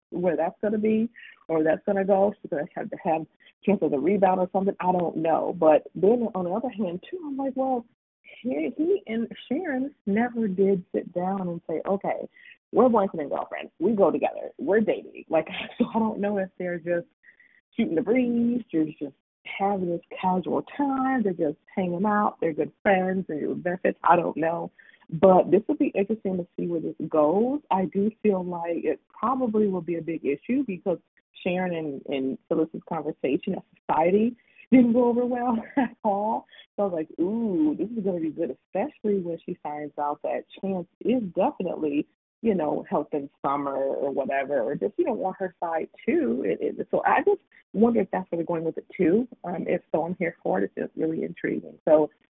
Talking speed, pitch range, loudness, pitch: 210 wpm, 165-230 Hz, -26 LUFS, 195 Hz